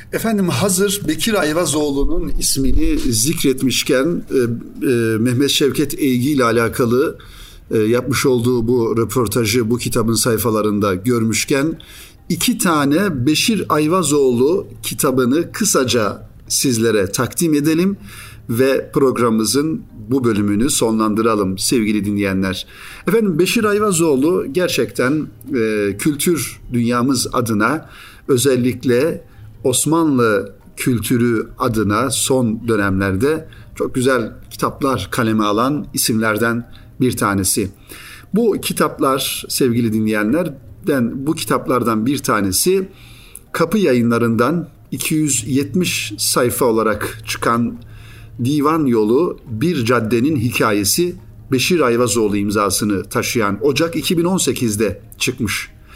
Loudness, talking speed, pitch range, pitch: -17 LUFS, 90 wpm, 110-145 Hz, 120 Hz